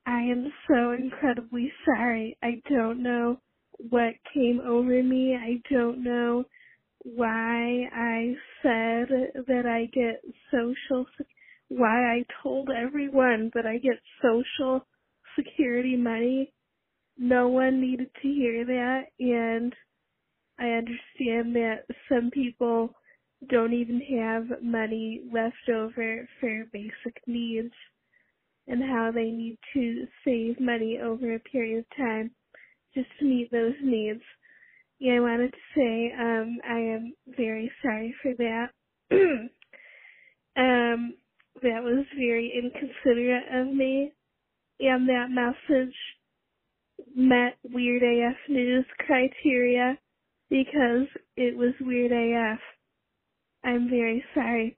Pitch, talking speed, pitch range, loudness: 245 Hz, 115 wpm, 235-260 Hz, -27 LUFS